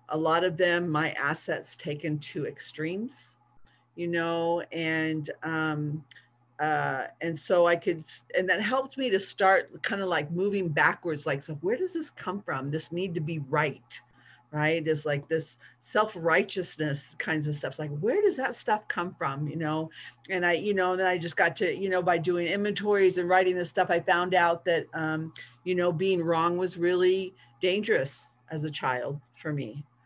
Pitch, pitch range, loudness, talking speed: 165 Hz, 150-185 Hz, -28 LUFS, 190 wpm